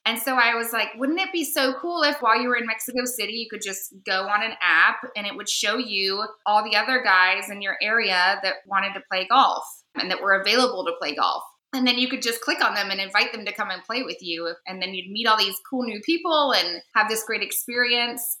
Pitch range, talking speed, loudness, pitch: 195-245 Hz, 260 wpm, -22 LUFS, 215 Hz